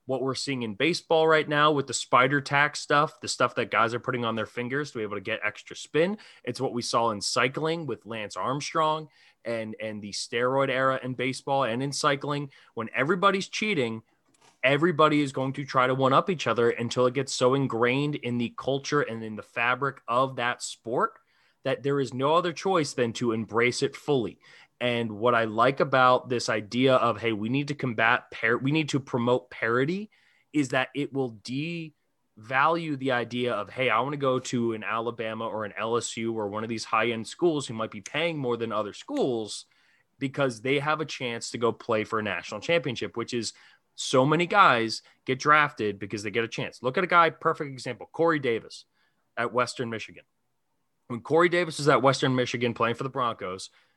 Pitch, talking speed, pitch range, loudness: 130 Hz, 210 wpm, 115-145 Hz, -26 LUFS